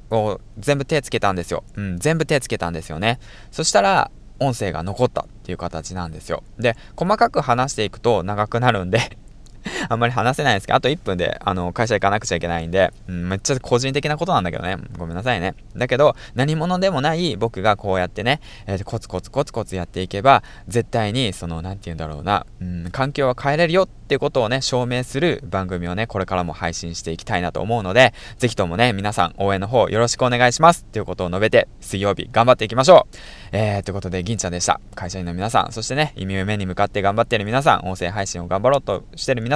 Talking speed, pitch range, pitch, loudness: 475 characters per minute, 95-125 Hz, 105 Hz, -20 LUFS